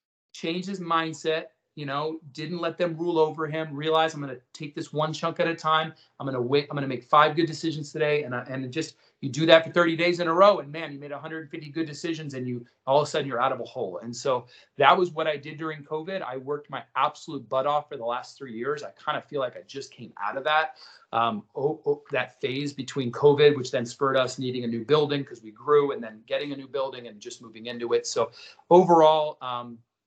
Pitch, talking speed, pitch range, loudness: 150 Hz, 255 wpm, 135-165 Hz, -26 LUFS